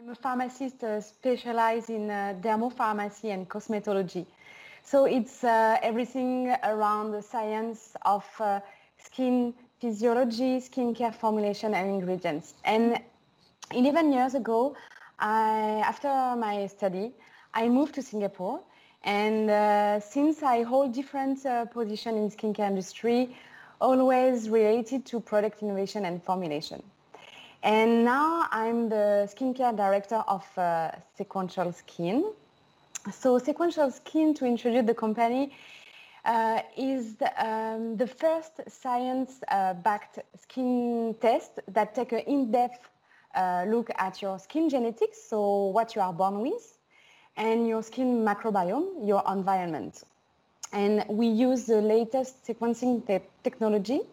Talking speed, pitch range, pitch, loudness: 125 wpm, 205-255 Hz, 225 Hz, -28 LUFS